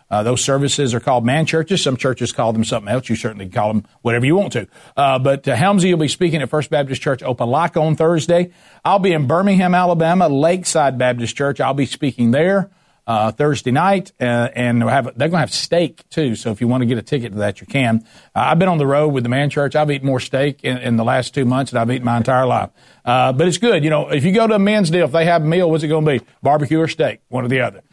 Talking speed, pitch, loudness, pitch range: 275 wpm, 140 Hz, -17 LUFS, 125-160 Hz